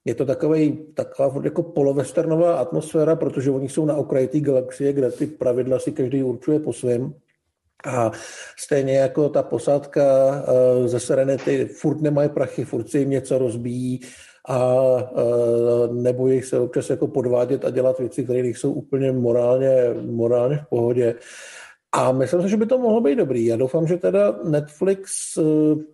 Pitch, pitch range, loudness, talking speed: 135 Hz, 125-150 Hz, -21 LUFS, 160 wpm